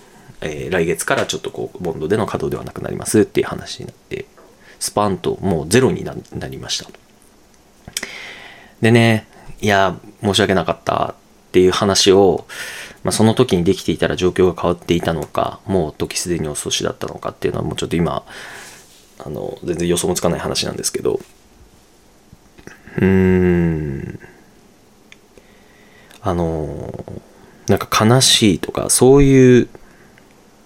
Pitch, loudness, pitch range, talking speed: 95 Hz, -17 LUFS, 85-110 Hz, 305 characters per minute